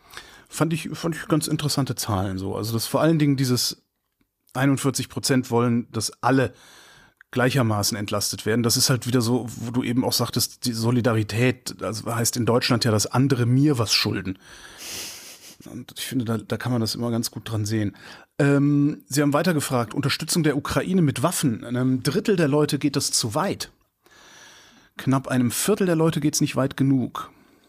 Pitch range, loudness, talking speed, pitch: 115-145 Hz, -23 LUFS, 185 wpm, 125 Hz